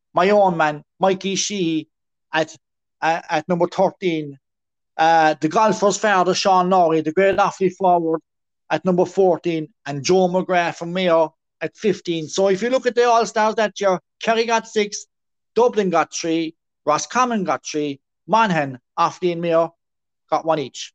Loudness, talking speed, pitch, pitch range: -19 LUFS, 160 wpm, 175 Hz, 160-195 Hz